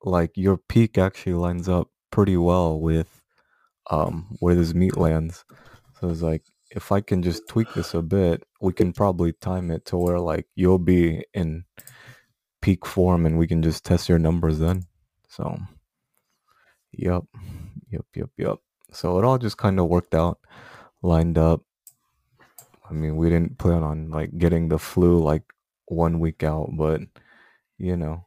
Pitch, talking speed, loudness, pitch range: 85 Hz, 165 wpm, -23 LUFS, 80-95 Hz